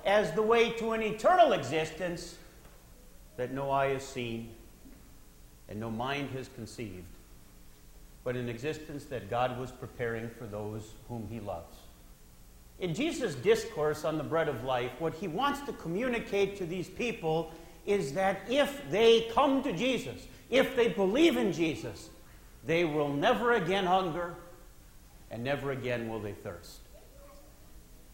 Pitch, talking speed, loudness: 150 Hz, 145 wpm, -31 LUFS